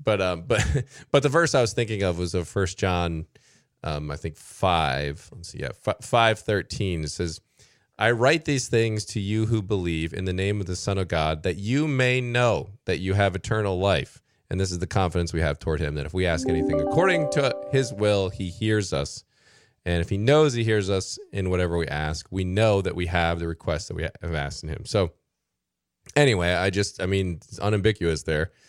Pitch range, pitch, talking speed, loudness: 85-110 Hz, 95 Hz, 220 wpm, -25 LUFS